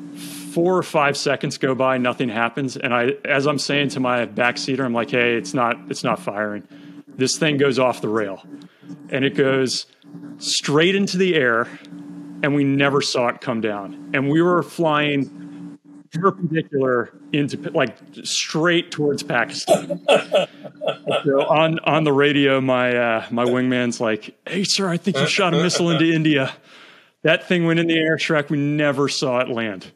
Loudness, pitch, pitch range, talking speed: -20 LUFS, 140 Hz, 125-155 Hz, 170 wpm